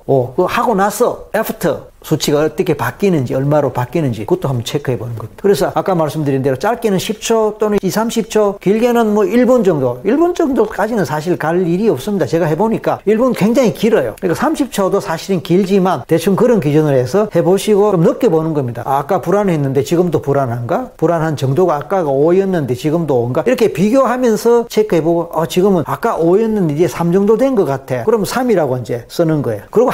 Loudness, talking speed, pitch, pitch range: -14 LUFS, 405 characters per minute, 180 Hz, 150-215 Hz